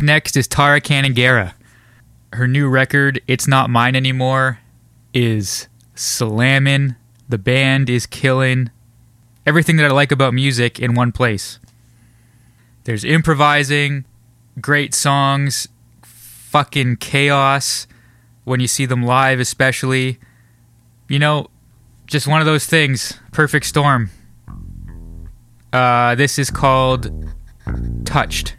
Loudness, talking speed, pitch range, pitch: -15 LUFS, 110 wpm, 115-140 Hz, 125 Hz